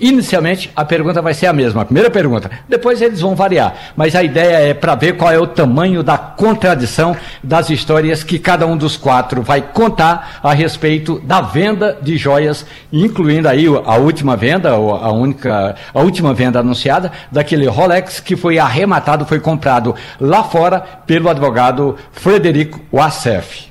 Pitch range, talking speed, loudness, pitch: 140-175 Hz, 165 wpm, -13 LUFS, 155 Hz